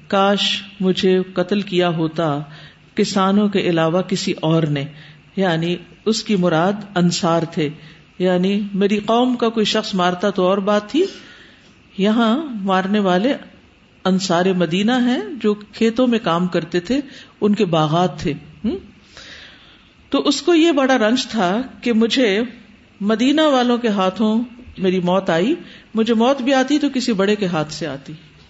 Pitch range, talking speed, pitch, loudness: 175-230 Hz, 150 wpm, 200 Hz, -18 LUFS